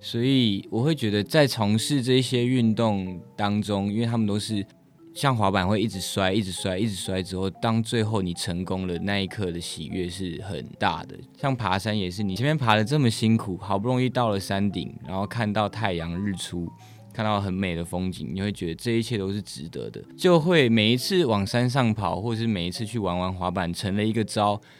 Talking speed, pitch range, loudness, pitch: 305 characters per minute, 95-115 Hz, -25 LUFS, 105 Hz